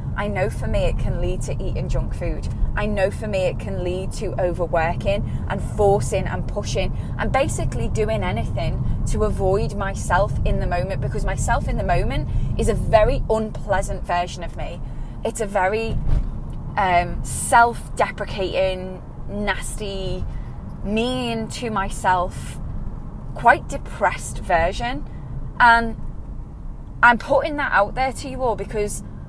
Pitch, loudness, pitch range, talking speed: 185 Hz, -22 LUFS, 135-225 Hz, 140 wpm